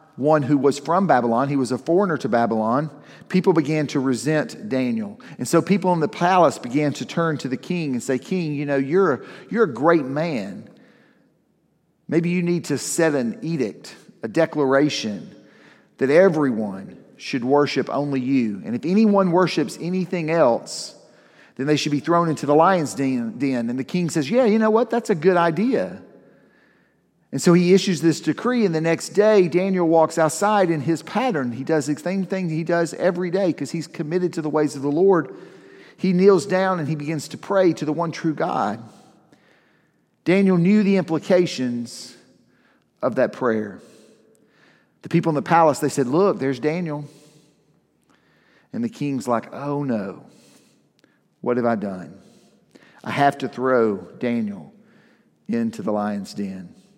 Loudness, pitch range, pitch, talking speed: -21 LUFS, 140-185 Hz, 160 Hz, 170 wpm